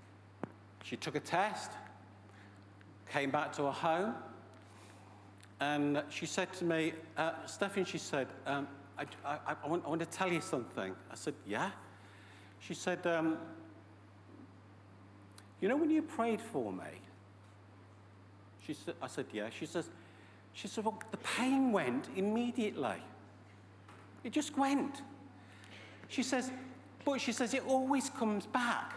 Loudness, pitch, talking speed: -37 LUFS, 140 Hz, 140 wpm